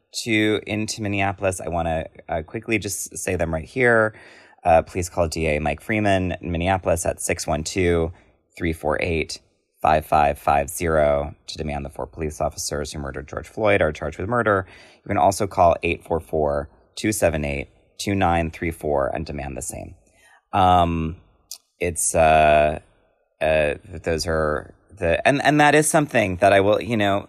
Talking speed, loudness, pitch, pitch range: 140 wpm, -21 LUFS, 85 Hz, 75-100 Hz